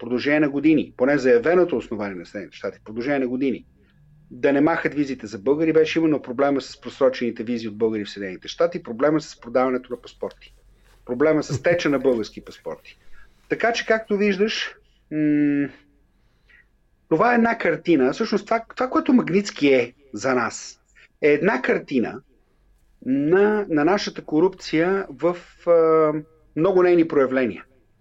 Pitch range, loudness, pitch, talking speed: 130-180 Hz, -21 LUFS, 150 Hz, 145 wpm